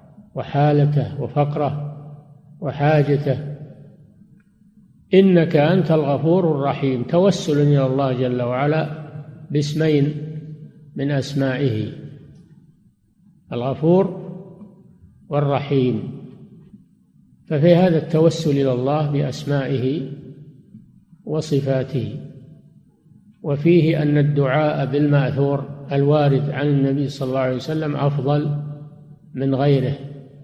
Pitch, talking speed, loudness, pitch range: 145 Hz, 75 wpm, -19 LUFS, 140-155 Hz